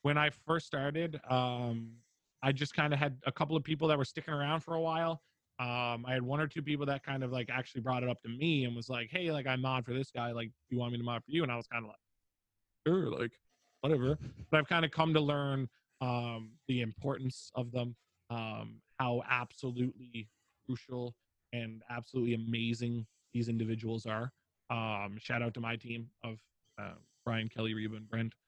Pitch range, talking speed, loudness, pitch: 115-140 Hz, 215 wpm, -36 LUFS, 125 Hz